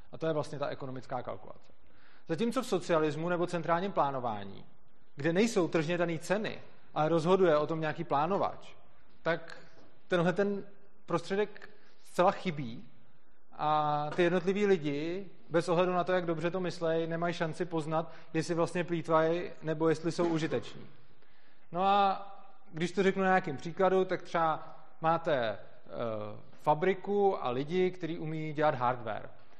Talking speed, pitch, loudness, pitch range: 145 wpm, 170 Hz, -32 LUFS, 155-185 Hz